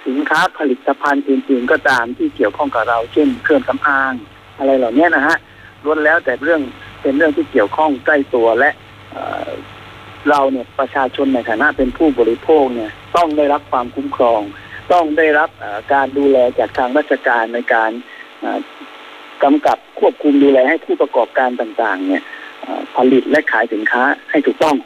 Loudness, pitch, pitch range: -15 LUFS, 135 Hz, 120-150 Hz